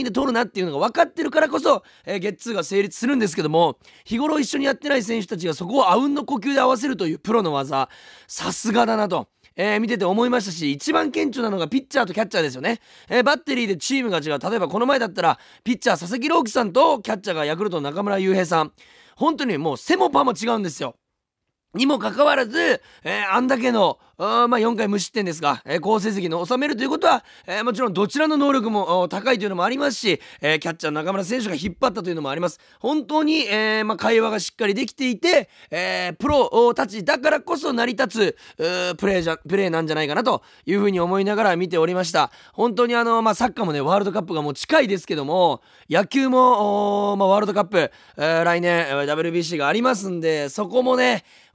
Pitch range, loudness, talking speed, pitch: 180-260 Hz, -21 LUFS, 470 characters per minute, 220 Hz